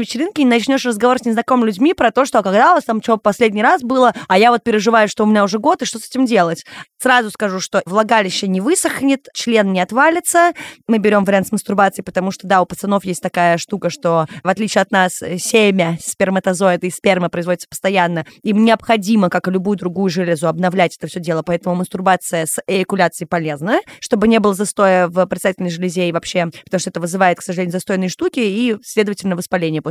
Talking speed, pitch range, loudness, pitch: 205 wpm, 180-230 Hz, -16 LUFS, 195 Hz